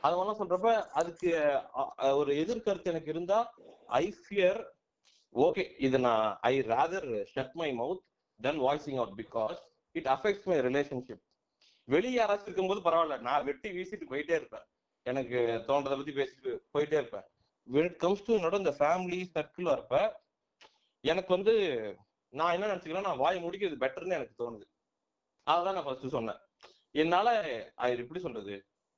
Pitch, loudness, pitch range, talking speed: 170 Hz, -32 LUFS, 135-200 Hz, 135 wpm